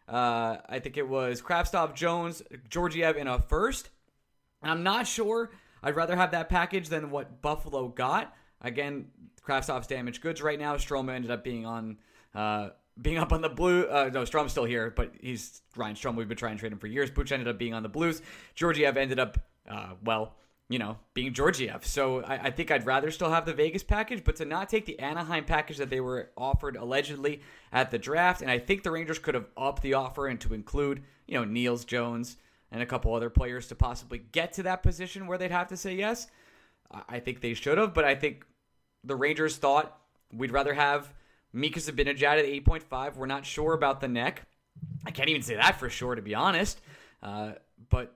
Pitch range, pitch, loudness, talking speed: 120-160 Hz, 140 Hz, -30 LUFS, 215 wpm